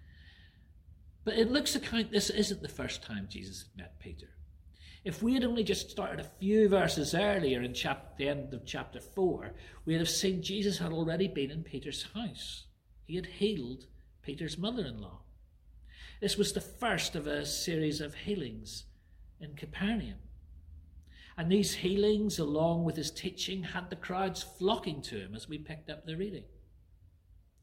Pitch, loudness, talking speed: 155 Hz, -33 LUFS, 165 wpm